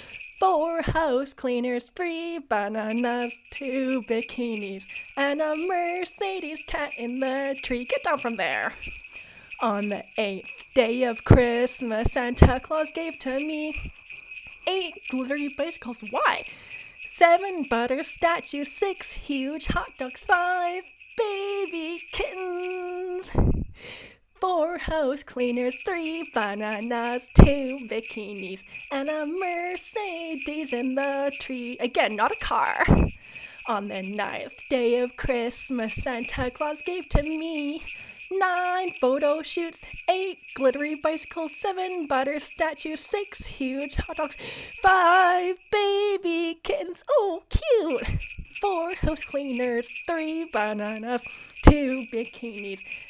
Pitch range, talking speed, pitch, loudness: 245-345 Hz, 110 wpm, 295 Hz, -26 LUFS